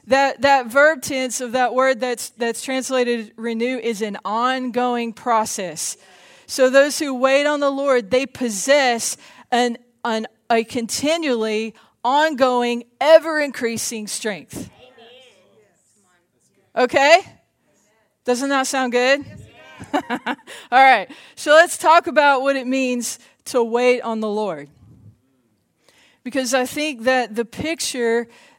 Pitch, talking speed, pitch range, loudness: 250 Hz, 120 wpm, 230-275 Hz, -19 LUFS